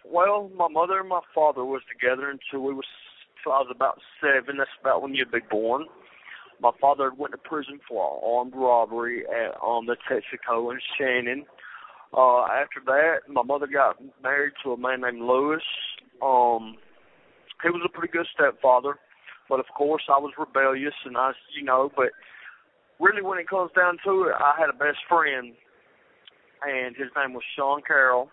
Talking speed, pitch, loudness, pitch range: 170 wpm, 135 Hz, -24 LUFS, 125-150 Hz